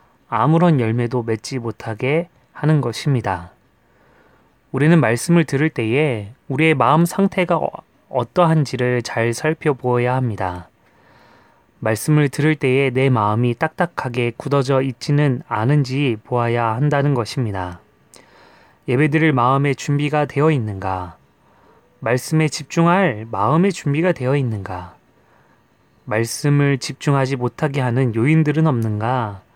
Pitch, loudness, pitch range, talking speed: 135 Hz, -18 LUFS, 120-155 Hz, 275 characters per minute